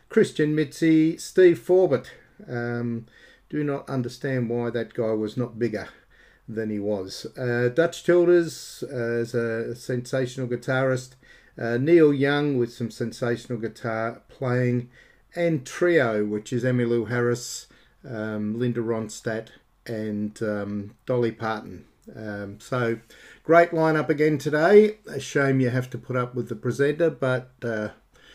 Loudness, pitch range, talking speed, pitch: -24 LUFS, 115-145 Hz, 140 wpm, 125 Hz